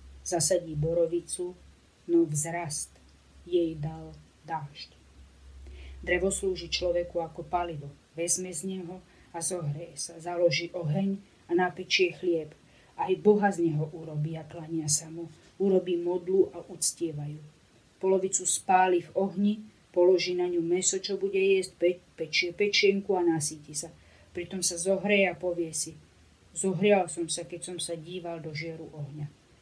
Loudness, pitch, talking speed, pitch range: -29 LUFS, 170 Hz, 140 wpm, 160-185 Hz